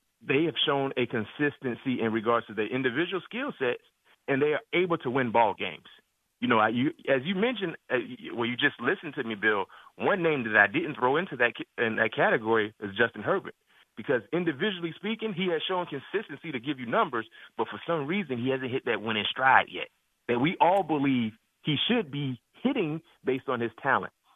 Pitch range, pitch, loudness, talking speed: 120-180 Hz, 140 Hz, -28 LUFS, 205 wpm